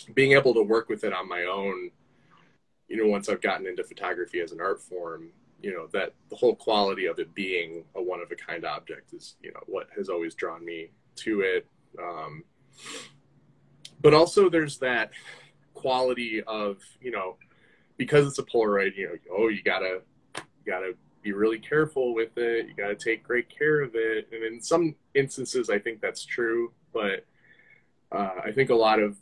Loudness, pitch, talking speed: -27 LUFS, 140 Hz, 190 wpm